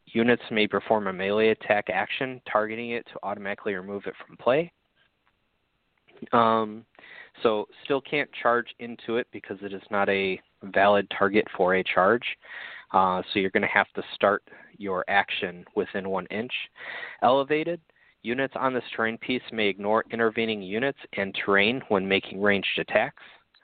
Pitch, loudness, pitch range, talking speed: 110 Hz, -26 LUFS, 100-120 Hz, 155 wpm